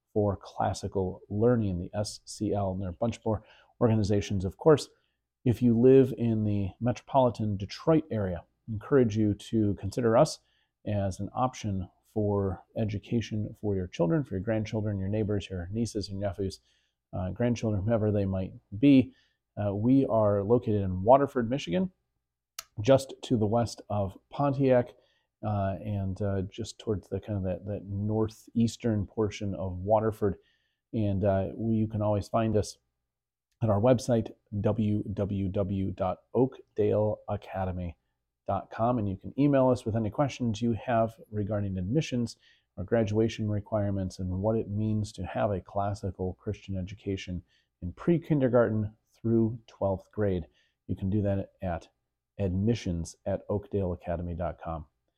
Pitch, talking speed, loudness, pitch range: 105 Hz, 140 wpm, -29 LUFS, 95-115 Hz